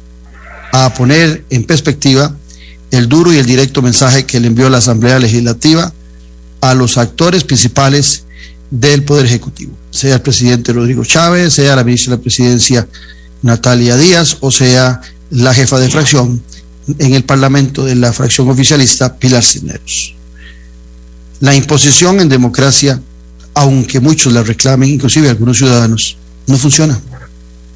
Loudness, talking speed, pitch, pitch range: -8 LUFS, 140 wpm, 125 Hz, 110-140 Hz